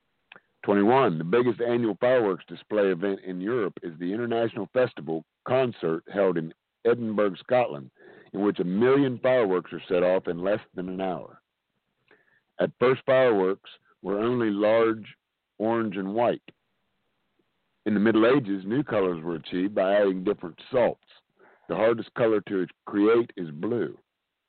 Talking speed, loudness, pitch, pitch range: 145 wpm, -26 LUFS, 105 Hz, 90-115 Hz